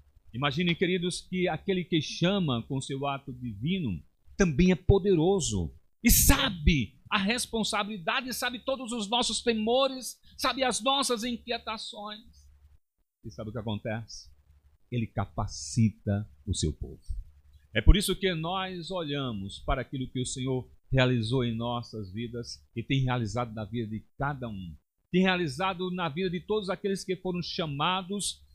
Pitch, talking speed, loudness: 145 Hz, 145 wpm, -29 LUFS